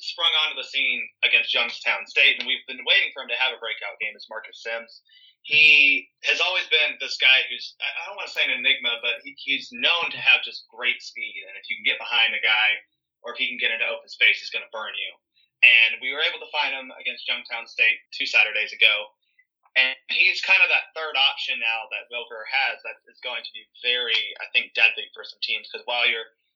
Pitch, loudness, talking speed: 155 Hz, -20 LUFS, 235 wpm